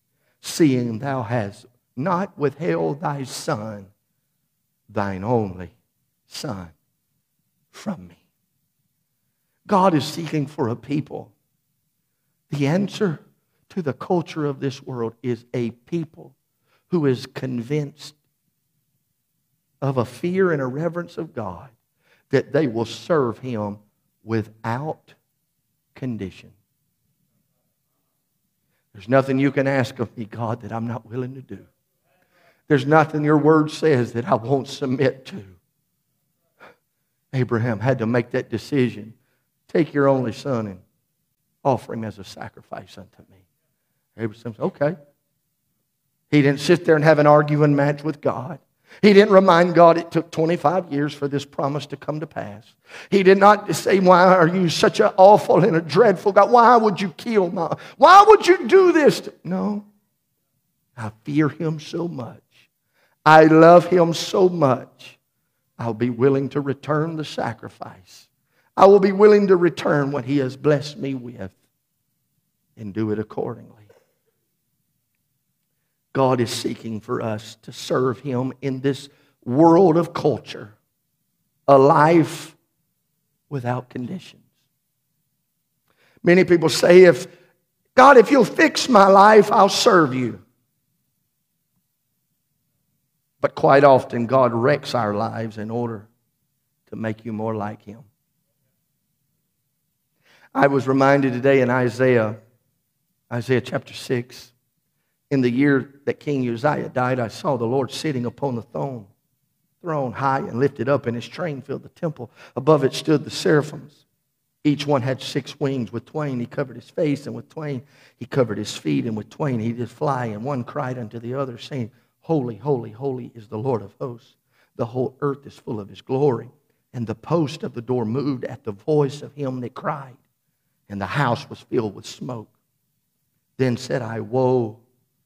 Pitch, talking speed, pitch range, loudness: 140 Hz, 150 wpm, 120-155 Hz, -19 LUFS